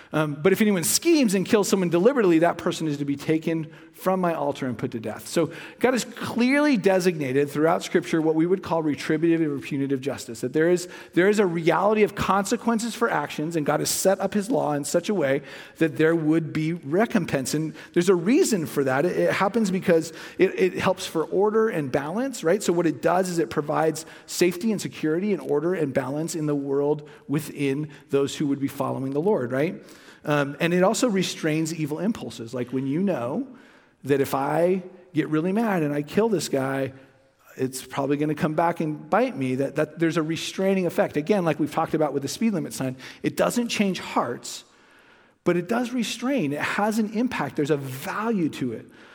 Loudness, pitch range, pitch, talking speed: -24 LUFS, 145-195 Hz, 165 Hz, 210 wpm